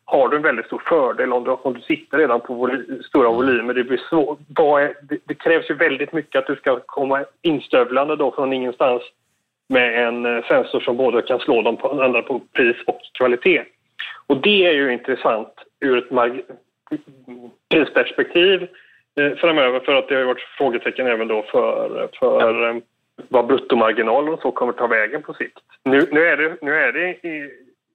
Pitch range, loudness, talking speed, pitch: 125-180 Hz, -18 LUFS, 180 wpm, 145 Hz